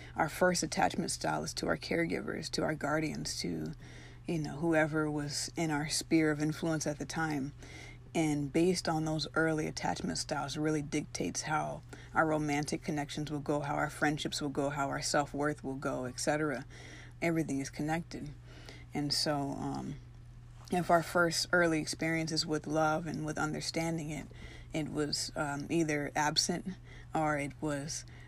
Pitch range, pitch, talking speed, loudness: 140-160 Hz, 150 Hz, 160 wpm, -34 LUFS